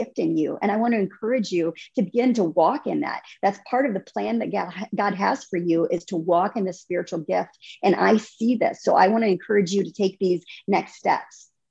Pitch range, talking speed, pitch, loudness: 180-225 Hz, 240 wpm, 200 Hz, -23 LUFS